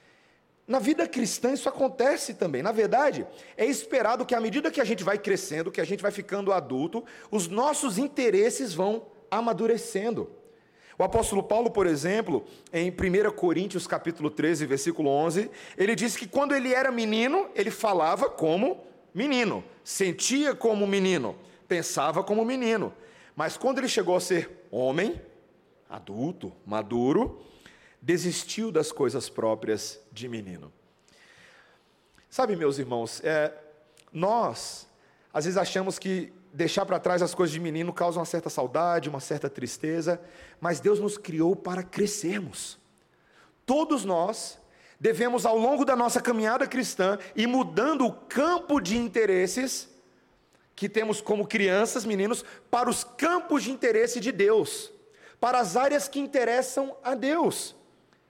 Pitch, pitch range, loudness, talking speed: 215 Hz, 175-260 Hz, -27 LUFS, 140 wpm